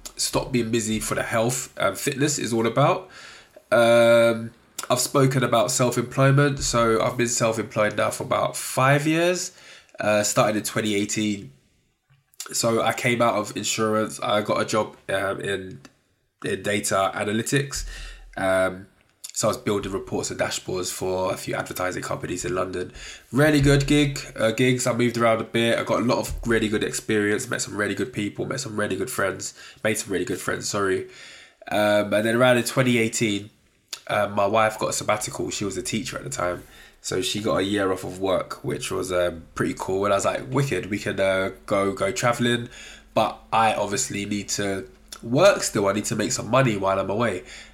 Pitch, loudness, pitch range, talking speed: 110 Hz, -23 LUFS, 100-125 Hz, 190 wpm